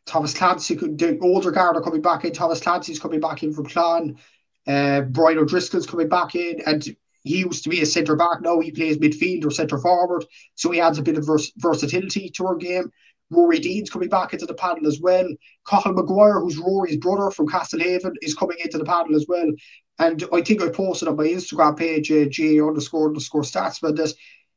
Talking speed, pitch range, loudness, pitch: 210 wpm, 155-180 Hz, -21 LUFS, 165 Hz